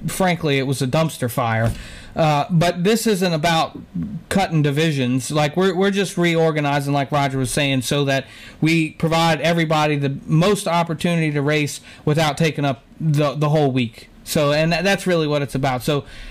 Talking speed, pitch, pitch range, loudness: 175 wpm, 150 Hz, 140-165 Hz, -19 LUFS